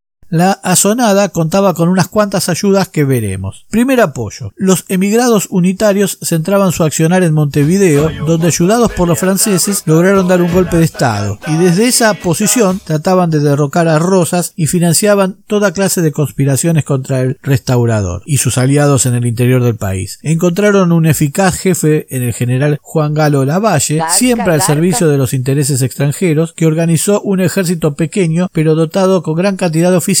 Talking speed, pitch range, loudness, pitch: 170 wpm, 150-190 Hz, -11 LUFS, 170 Hz